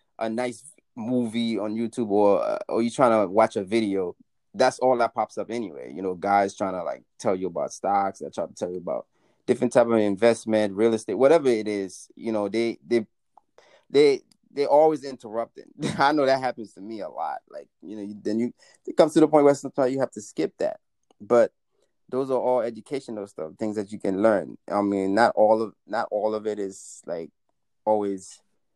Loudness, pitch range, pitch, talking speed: -24 LUFS, 105-125 Hz, 110 Hz, 210 wpm